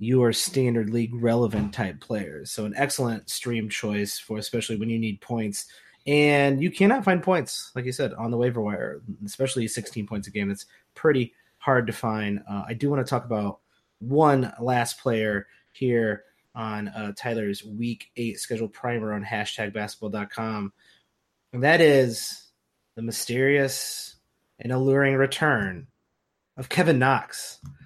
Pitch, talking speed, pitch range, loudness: 115 Hz, 155 wpm, 105-130 Hz, -25 LUFS